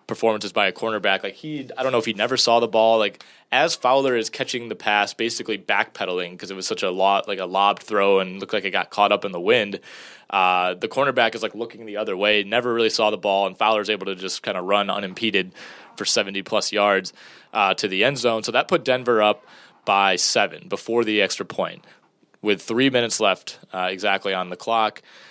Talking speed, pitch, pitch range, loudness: 230 wpm, 105 Hz, 100-115 Hz, -21 LUFS